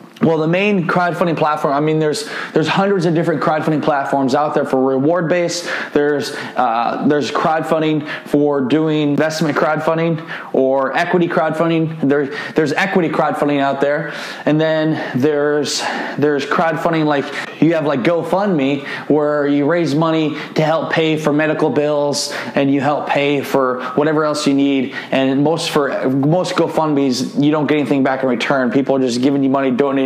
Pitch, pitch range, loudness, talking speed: 150 Hz, 140-160 Hz, -16 LUFS, 165 wpm